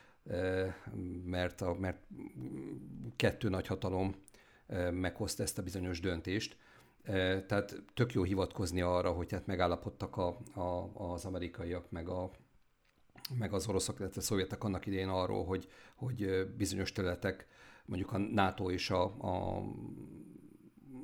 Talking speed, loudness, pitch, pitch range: 125 wpm, -37 LUFS, 95 Hz, 90-100 Hz